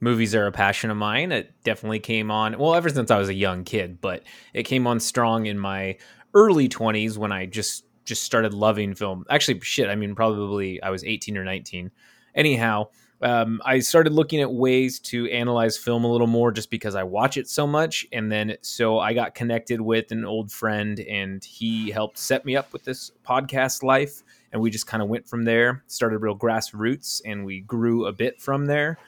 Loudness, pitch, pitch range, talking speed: -23 LUFS, 115 Hz, 105-125 Hz, 210 wpm